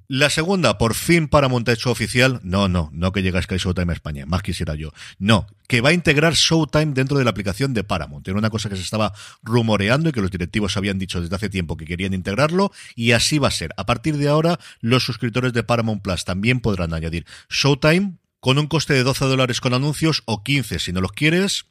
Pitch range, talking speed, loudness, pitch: 95-140 Hz, 230 wpm, -20 LUFS, 115 Hz